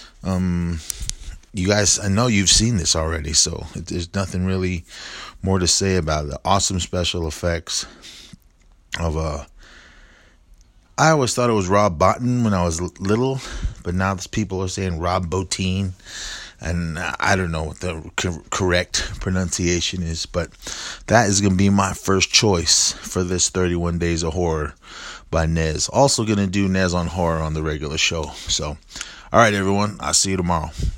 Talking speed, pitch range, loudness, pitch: 165 wpm, 80-95 Hz, -20 LUFS, 90 Hz